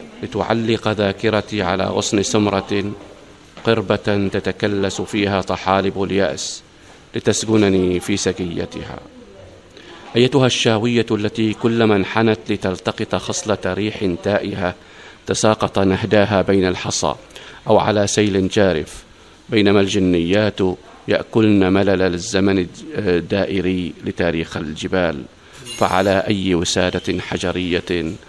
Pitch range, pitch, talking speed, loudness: 95-110 Hz, 100 Hz, 90 wpm, -18 LUFS